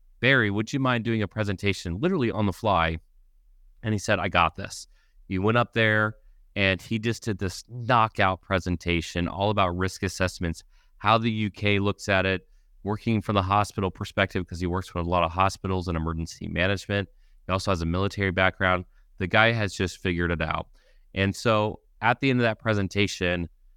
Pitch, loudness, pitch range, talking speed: 95 Hz, -25 LUFS, 90-105 Hz, 190 wpm